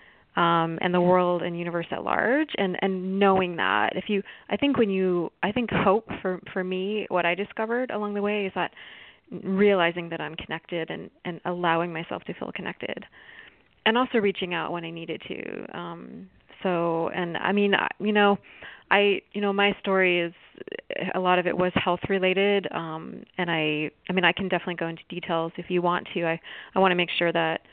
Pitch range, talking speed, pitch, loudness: 170-200 Hz, 200 wpm, 180 Hz, -25 LUFS